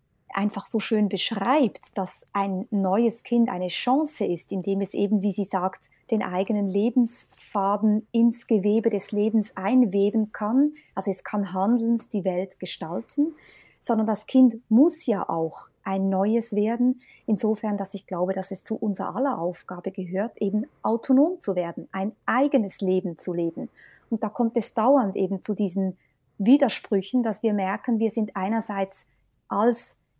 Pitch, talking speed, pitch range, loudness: 210 Hz, 155 wpm, 195-230 Hz, -25 LUFS